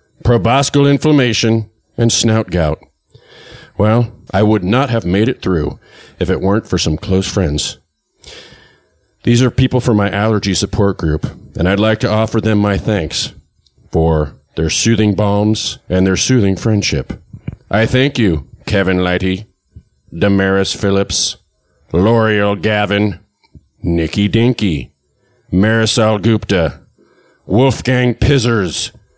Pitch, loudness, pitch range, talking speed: 105 Hz, -14 LUFS, 95-115 Hz, 120 wpm